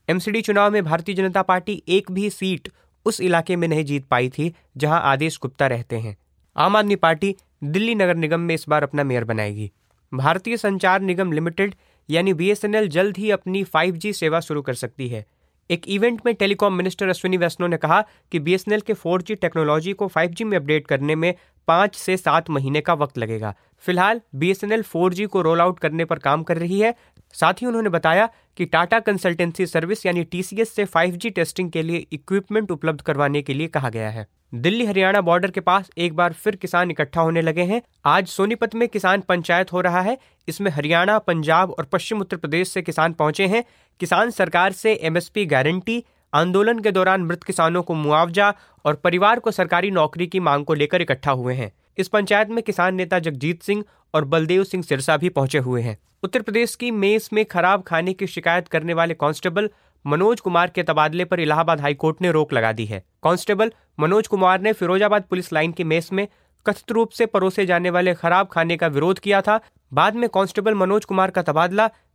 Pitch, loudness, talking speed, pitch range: 180 Hz, -20 LUFS, 195 wpm, 160-200 Hz